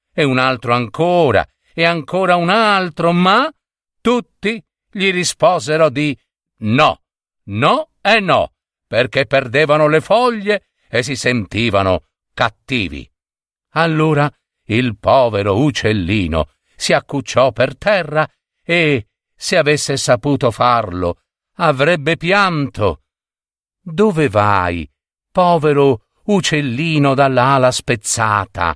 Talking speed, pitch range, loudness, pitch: 95 wpm, 115-170 Hz, -15 LUFS, 140 Hz